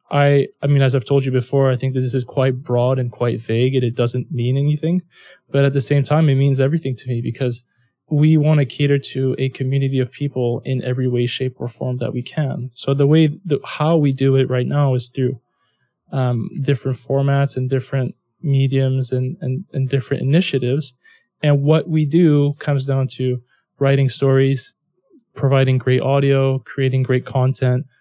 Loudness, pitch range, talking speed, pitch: -18 LUFS, 130-140 Hz, 190 wpm, 135 Hz